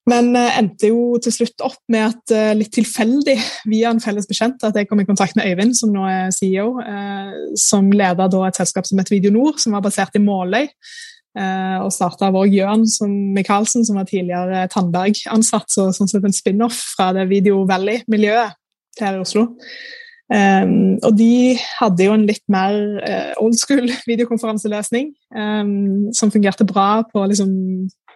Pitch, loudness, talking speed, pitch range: 210 Hz, -16 LUFS, 180 wpm, 195-230 Hz